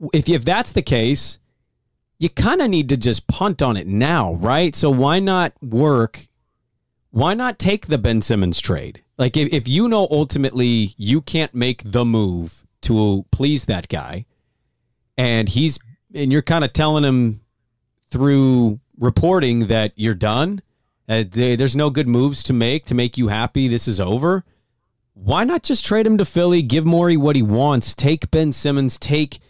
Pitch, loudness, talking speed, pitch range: 135 Hz, -18 LUFS, 175 wpm, 115-155 Hz